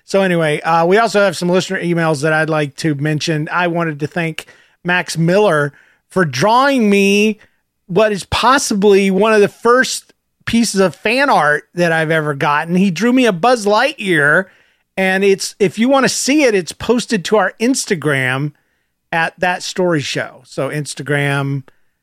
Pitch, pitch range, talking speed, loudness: 180 Hz, 155-210 Hz, 170 wpm, -14 LUFS